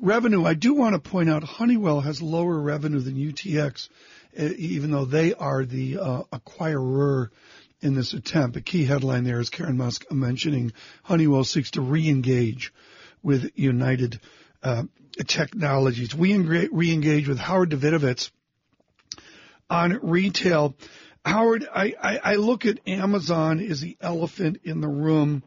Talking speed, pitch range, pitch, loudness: 140 wpm, 135-175 Hz, 155 Hz, -24 LUFS